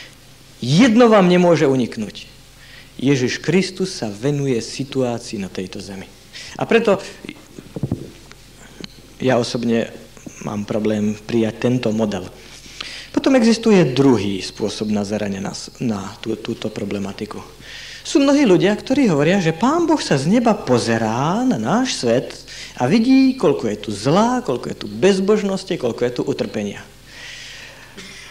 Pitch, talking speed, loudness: 130 Hz, 125 wpm, -18 LUFS